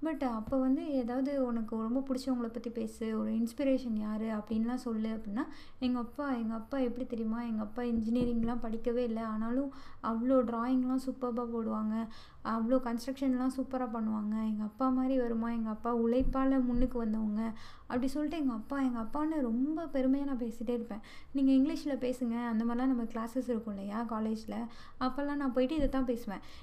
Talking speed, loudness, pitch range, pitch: 160 wpm, -34 LUFS, 225-265 Hz, 245 Hz